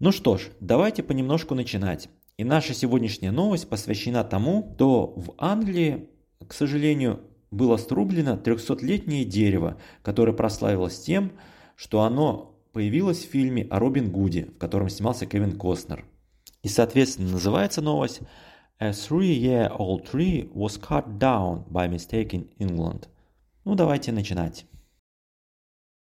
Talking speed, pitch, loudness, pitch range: 125 wpm, 115 Hz, -25 LUFS, 95-145 Hz